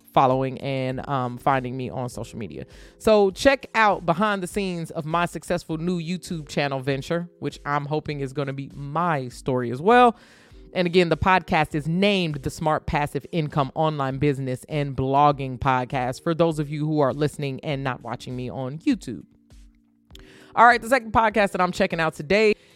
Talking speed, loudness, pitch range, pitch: 185 wpm, -23 LUFS, 130-180 Hz, 150 Hz